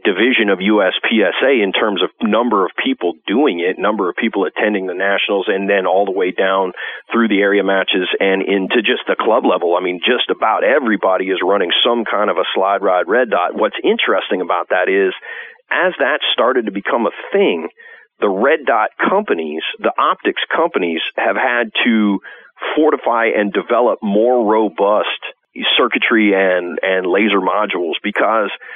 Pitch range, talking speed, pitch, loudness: 95-125 Hz, 170 wpm, 100 Hz, -15 LUFS